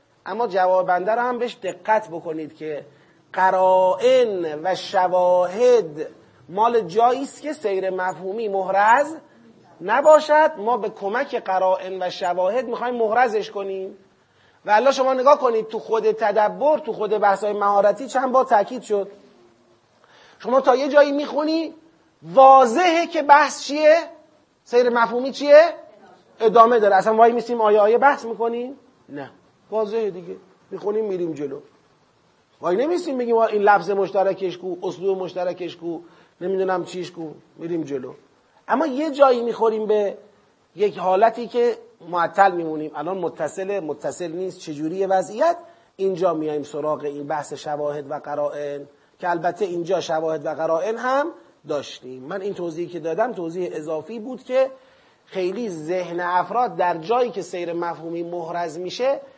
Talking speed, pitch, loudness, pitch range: 140 wpm, 200 Hz, -20 LUFS, 175-245 Hz